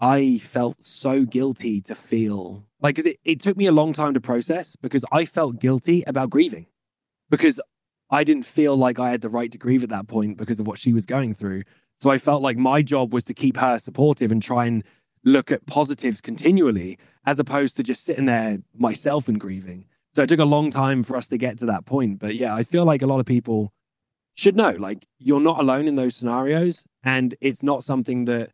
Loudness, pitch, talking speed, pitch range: -21 LUFS, 130 Hz, 225 wpm, 120-145 Hz